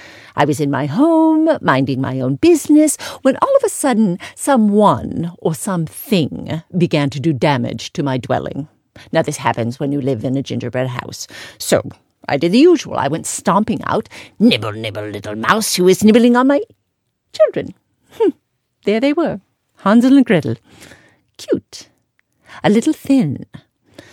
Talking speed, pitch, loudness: 160 wpm, 180 Hz, -16 LUFS